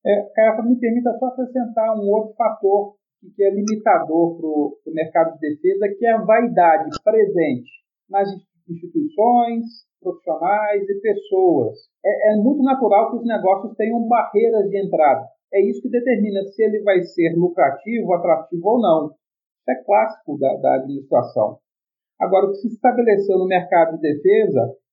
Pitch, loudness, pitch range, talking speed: 210 Hz, -18 LUFS, 180-235 Hz, 155 wpm